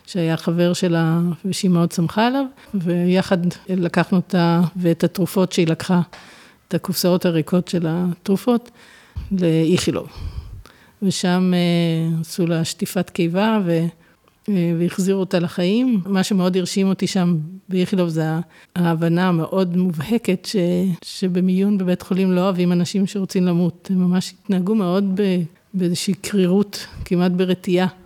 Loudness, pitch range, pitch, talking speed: -20 LUFS, 170-190 Hz, 180 Hz, 125 wpm